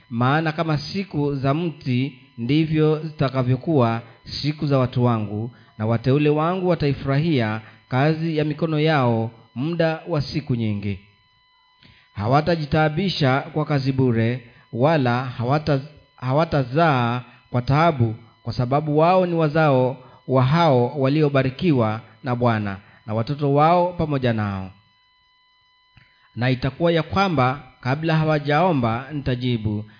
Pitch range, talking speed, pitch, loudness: 120-155 Hz, 110 wpm, 135 Hz, -21 LUFS